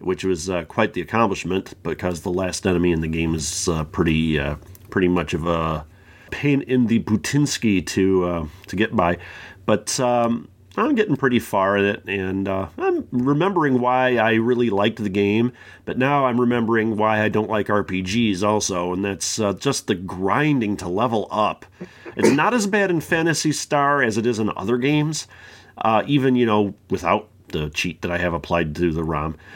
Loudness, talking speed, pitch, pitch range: -21 LUFS, 190 wpm, 105 Hz, 90-125 Hz